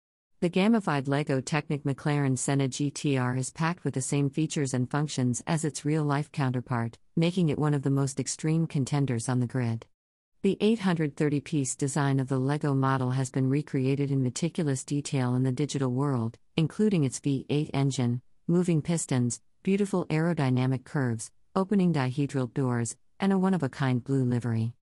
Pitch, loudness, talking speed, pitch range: 140 Hz, -28 LUFS, 165 wpm, 130-155 Hz